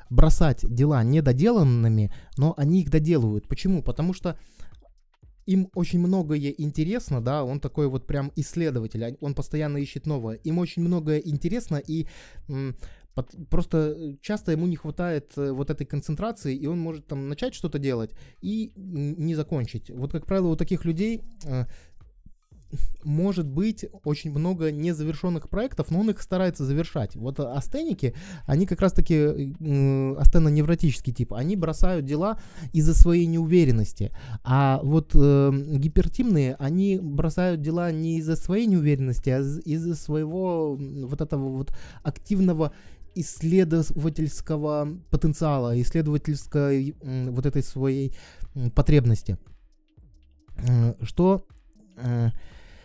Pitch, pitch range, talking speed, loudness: 150 Hz, 135-170 Hz, 125 wpm, -25 LUFS